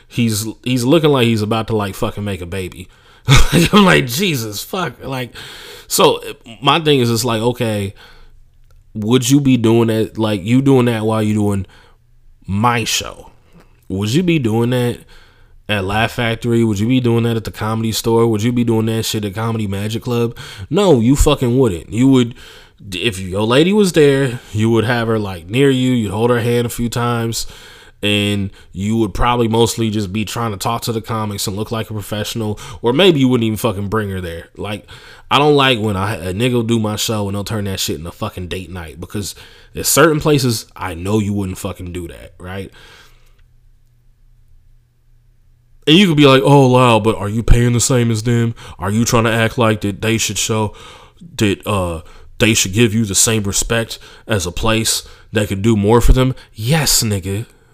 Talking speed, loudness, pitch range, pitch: 205 wpm, -15 LUFS, 105-120 Hz, 115 Hz